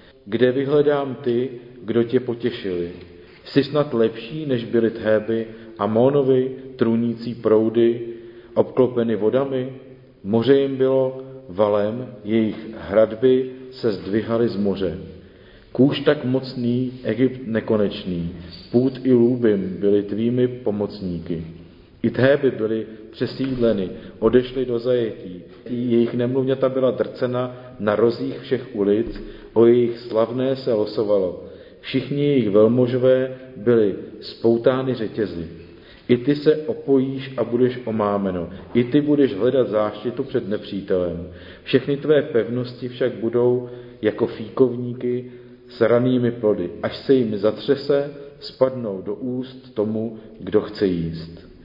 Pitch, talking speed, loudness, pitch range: 120 Hz, 115 wpm, -21 LUFS, 105-130 Hz